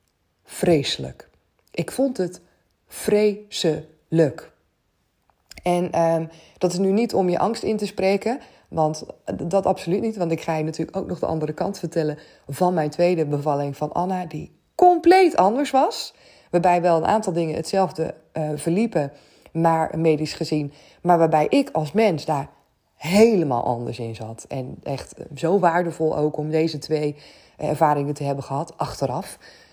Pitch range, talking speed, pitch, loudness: 155-190 Hz, 160 wpm, 165 Hz, -22 LUFS